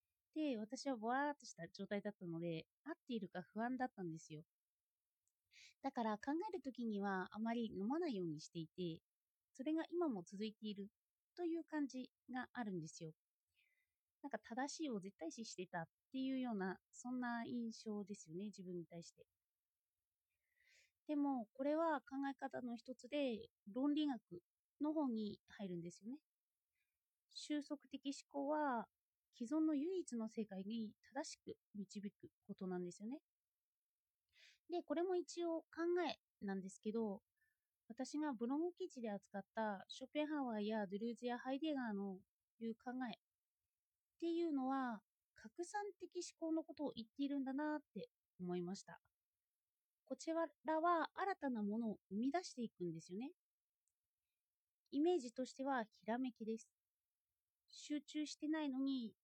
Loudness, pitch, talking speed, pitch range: -46 LUFS, 245 Hz, 295 characters per minute, 205-295 Hz